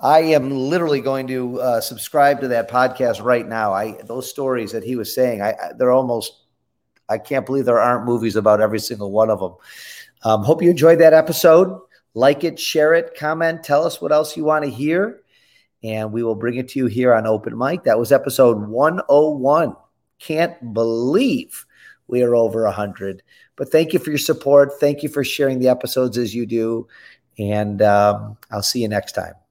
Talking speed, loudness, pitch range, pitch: 195 wpm, -18 LUFS, 115-150 Hz, 125 Hz